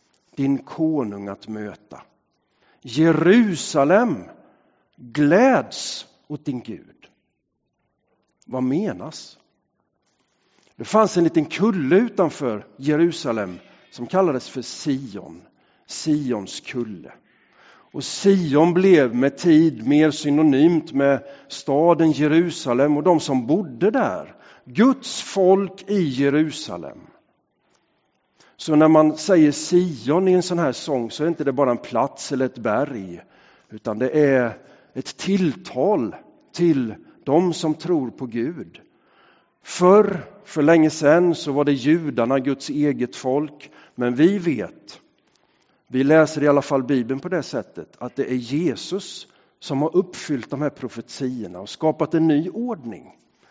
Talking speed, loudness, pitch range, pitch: 125 wpm, -20 LUFS, 135-170 Hz, 150 Hz